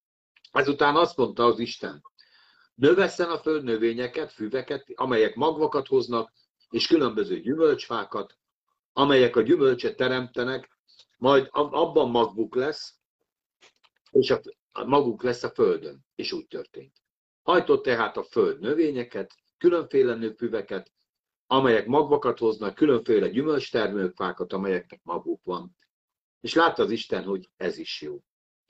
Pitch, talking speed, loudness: 365 Hz, 115 wpm, -25 LUFS